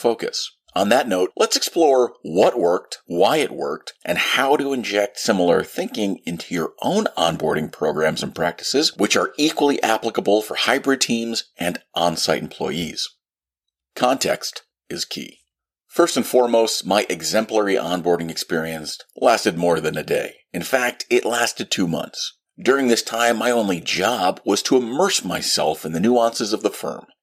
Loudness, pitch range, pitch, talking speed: -20 LUFS, 85-120 Hz, 110 Hz, 160 wpm